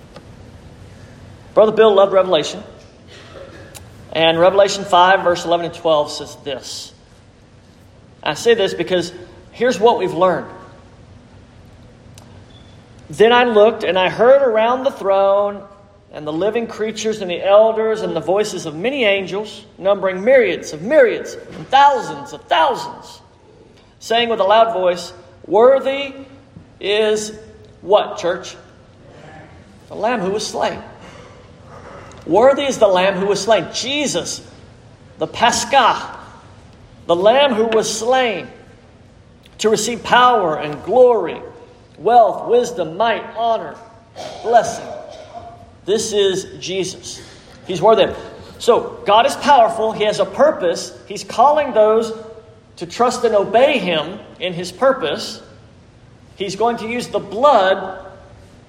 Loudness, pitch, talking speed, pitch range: -16 LUFS, 200 Hz, 125 wpm, 160-230 Hz